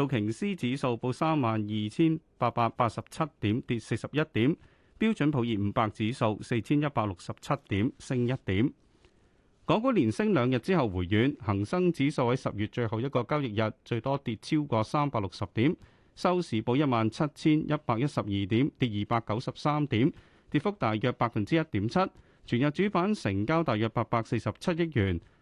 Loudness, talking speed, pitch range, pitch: -29 LUFS, 280 characters per minute, 110-150 Hz, 120 Hz